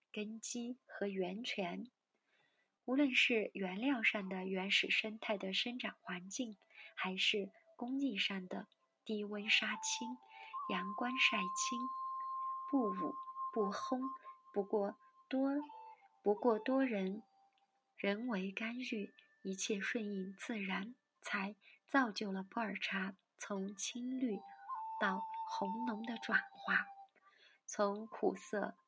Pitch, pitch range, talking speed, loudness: 225 Hz, 200-270 Hz, 155 characters per minute, -39 LUFS